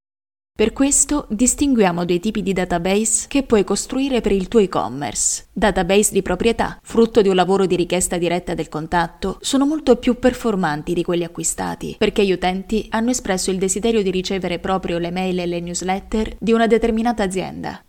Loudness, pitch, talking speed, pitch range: -19 LUFS, 195 Hz, 175 wpm, 180-230 Hz